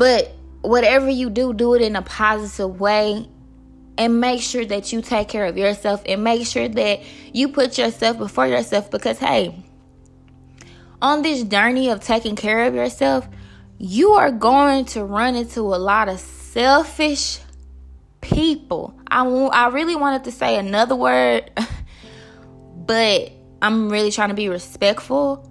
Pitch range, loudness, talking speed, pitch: 195-255 Hz, -18 LUFS, 155 wpm, 220 Hz